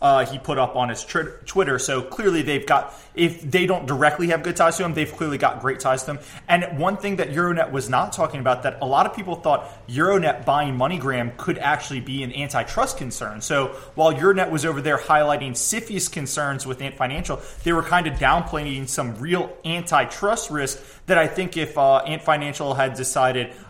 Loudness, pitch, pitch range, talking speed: -22 LUFS, 145 Hz, 135-170 Hz, 210 wpm